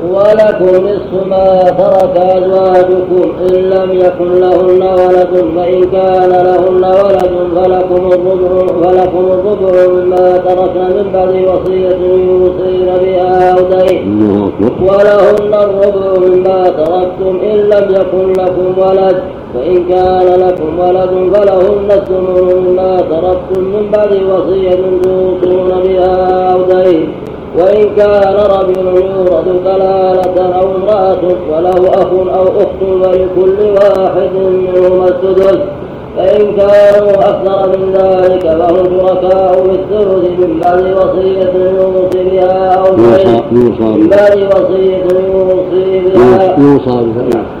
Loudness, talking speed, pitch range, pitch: -8 LUFS, 105 wpm, 180-190 Hz, 185 Hz